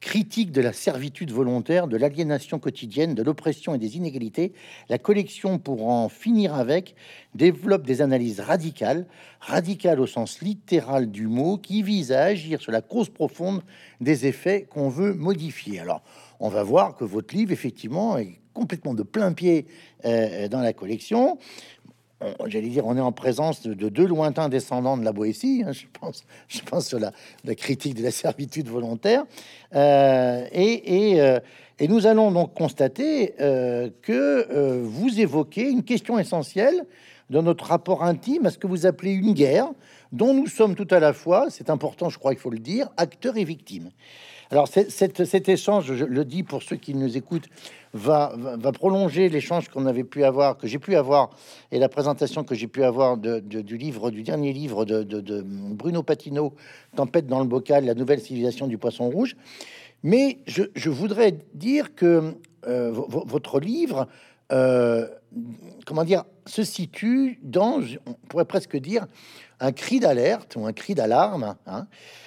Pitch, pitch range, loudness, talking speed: 155 Hz, 130-195 Hz, -23 LUFS, 175 wpm